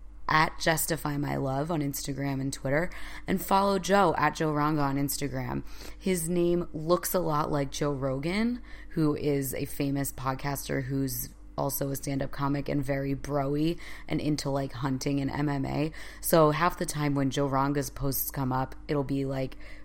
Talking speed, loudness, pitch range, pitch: 175 wpm, -29 LUFS, 135-155 Hz, 145 Hz